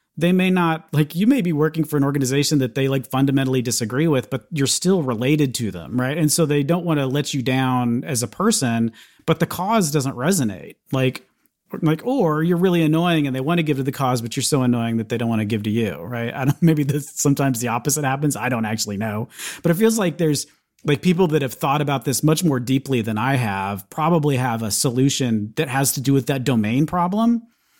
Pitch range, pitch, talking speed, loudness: 125-160 Hz, 140 Hz, 235 wpm, -20 LUFS